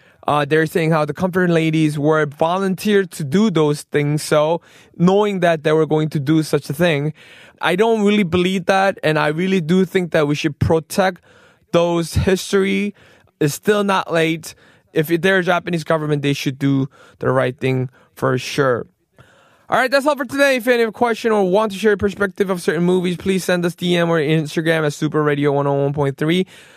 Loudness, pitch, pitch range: -18 LUFS, 170 Hz, 150-190 Hz